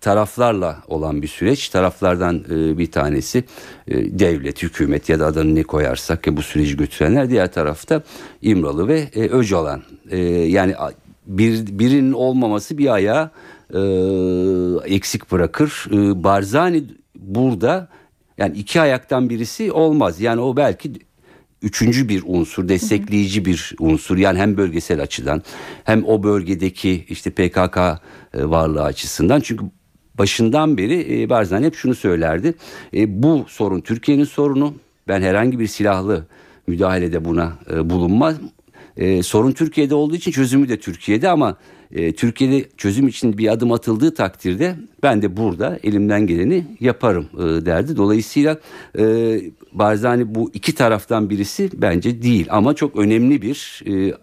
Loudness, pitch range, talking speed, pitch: -18 LUFS, 90-120 Hz, 125 wpm, 105 Hz